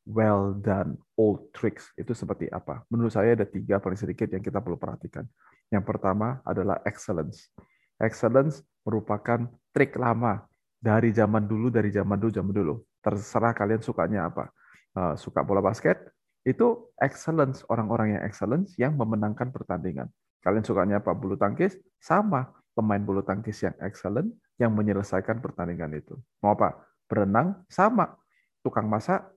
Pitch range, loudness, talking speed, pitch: 100-120 Hz, -27 LUFS, 140 wpm, 110 Hz